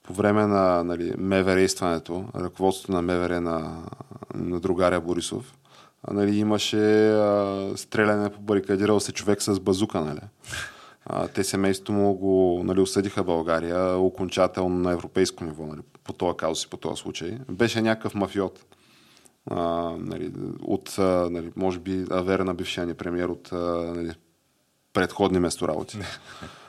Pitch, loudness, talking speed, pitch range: 95 Hz, -25 LUFS, 140 wpm, 85-100 Hz